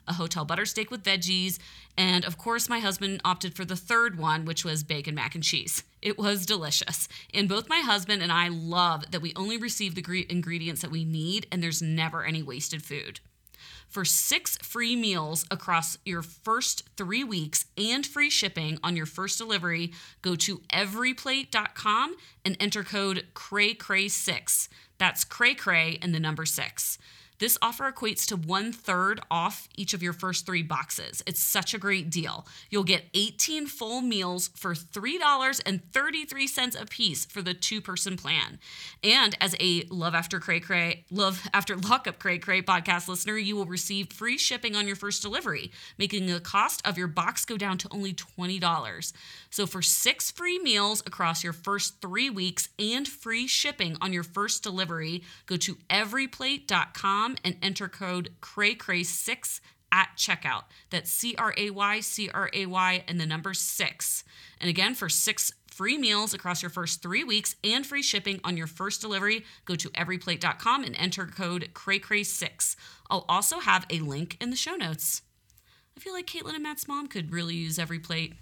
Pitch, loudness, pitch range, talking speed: 190 Hz, -27 LUFS, 170-210 Hz, 170 wpm